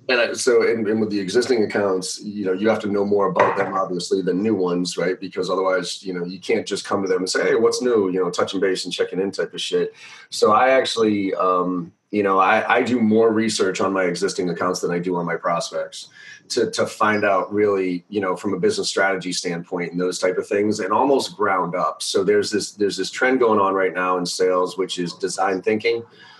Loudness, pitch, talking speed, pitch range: -20 LUFS, 95 Hz, 235 wpm, 90-110 Hz